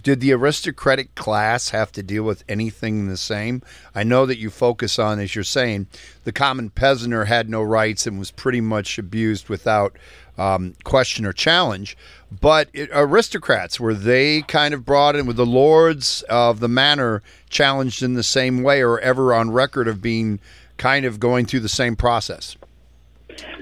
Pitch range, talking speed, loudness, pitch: 105-135 Hz, 175 wpm, -19 LUFS, 120 Hz